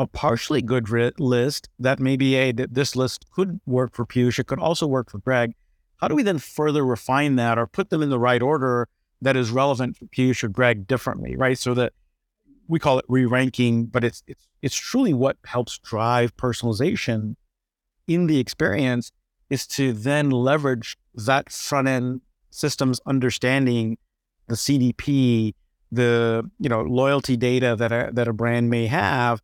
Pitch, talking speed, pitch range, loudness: 125 Hz, 175 wpm, 120-135 Hz, -22 LUFS